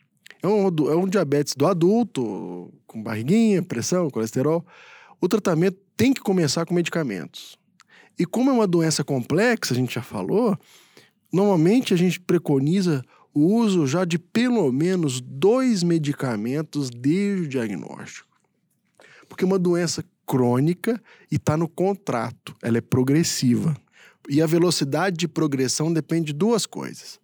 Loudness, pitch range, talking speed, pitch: -22 LUFS, 140-190 Hz, 140 wpm, 165 Hz